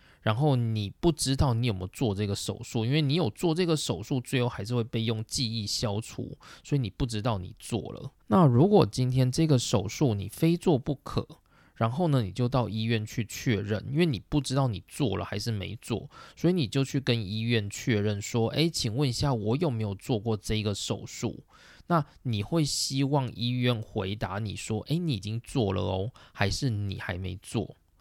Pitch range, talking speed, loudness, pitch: 110-140 Hz, 285 characters per minute, -28 LUFS, 120 Hz